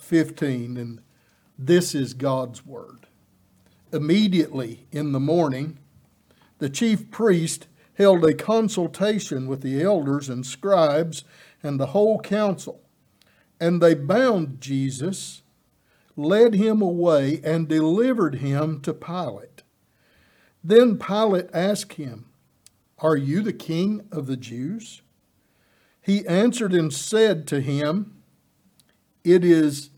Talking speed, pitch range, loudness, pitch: 110 wpm, 140-195 Hz, -22 LUFS, 160 Hz